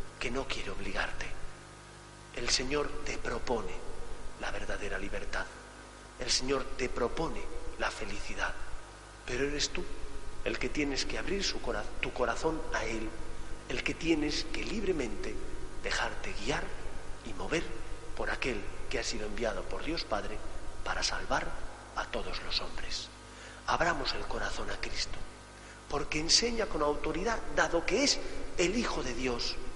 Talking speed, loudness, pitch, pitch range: 145 wpm, -34 LUFS, 125 Hz, 105-145 Hz